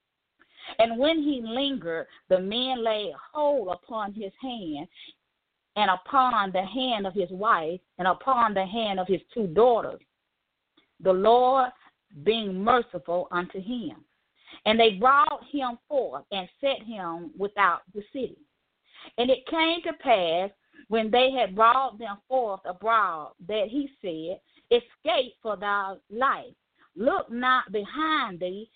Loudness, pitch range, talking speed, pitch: -26 LUFS, 195-270 Hz, 140 wpm, 230 Hz